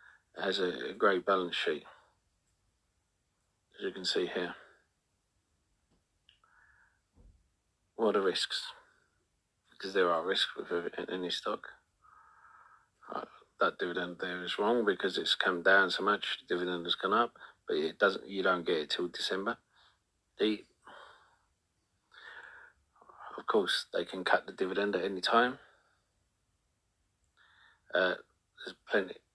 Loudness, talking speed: -32 LUFS, 120 wpm